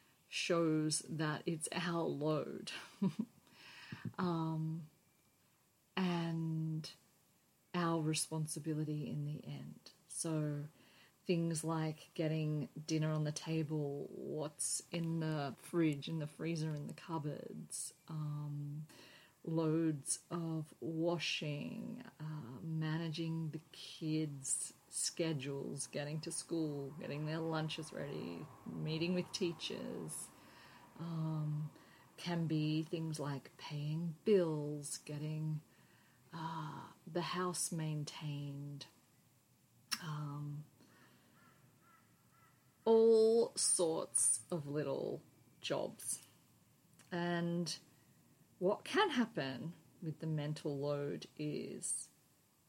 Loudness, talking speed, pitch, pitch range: -40 LUFS, 85 wpm, 160 Hz, 150-170 Hz